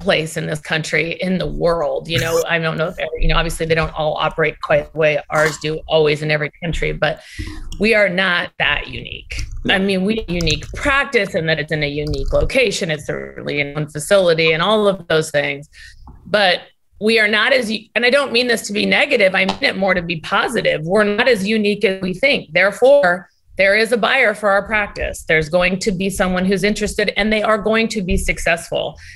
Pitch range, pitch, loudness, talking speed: 155-210 Hz, 185 Hz, -17 LUFS, 220 wpm